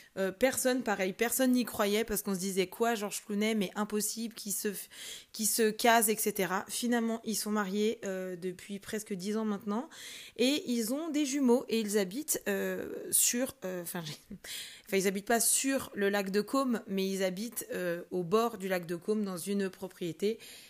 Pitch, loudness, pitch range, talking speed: 210 Hz, -32 LUFS, 195-230 Hz, 180 wpm